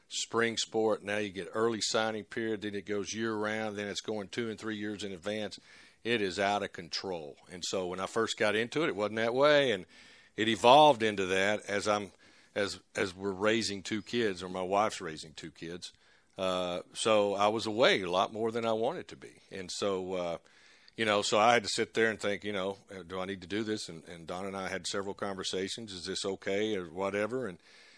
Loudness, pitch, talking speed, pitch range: -31 LUFS, 105 Hz, 225 wpm, 95-110 Hz